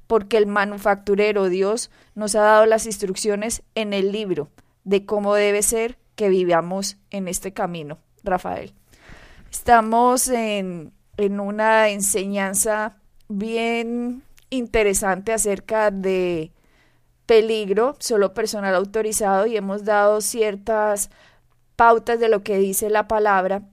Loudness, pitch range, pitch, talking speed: -20 LUFS, 195-220 Hz, 210 Hz, 115 wpm